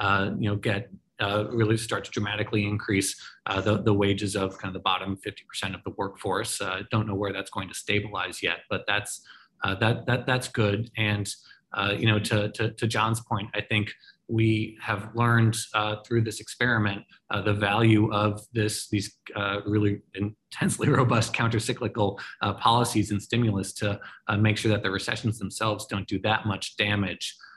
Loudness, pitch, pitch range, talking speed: -27 LUFS, 105 Hz, 100-110 Hz, 185 wpm